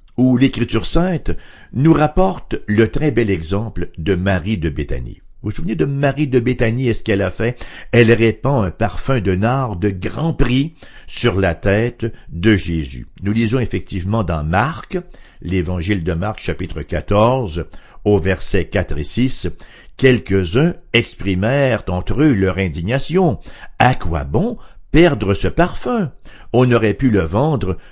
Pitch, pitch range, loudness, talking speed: 110 Hz, 95-130 Hz, -17 LUFS, 155 wpm